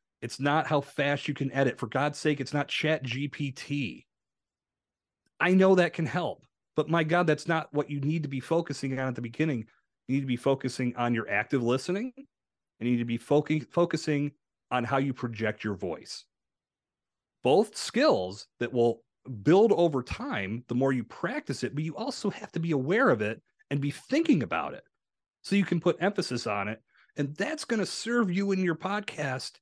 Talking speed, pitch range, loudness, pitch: 200 wpm, 125-170 Hz, -29 LUFS, 145 Hz